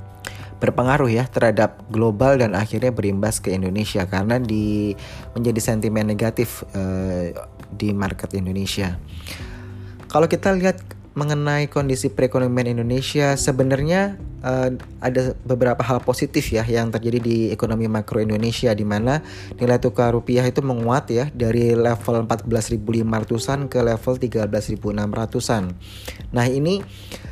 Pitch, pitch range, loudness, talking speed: 115 Hz, 105-125 Hz, -21 LUFS, 120 wpm